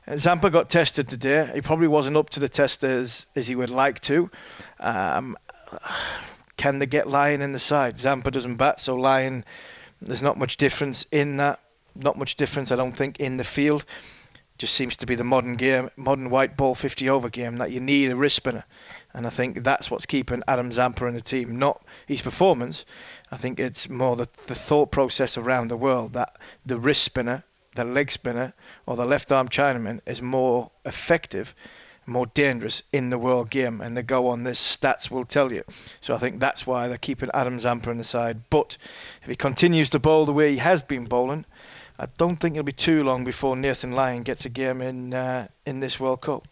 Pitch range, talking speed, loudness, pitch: 125-140 Hz, 205 wpm, -24 LUFS, 130 Hz